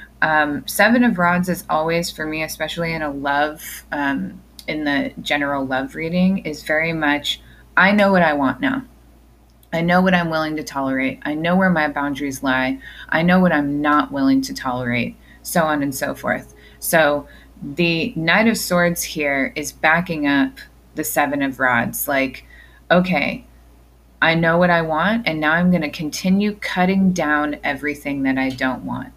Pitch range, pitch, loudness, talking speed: 140-170 Hz, 150 Hz, -19 LUFS, 175 wpm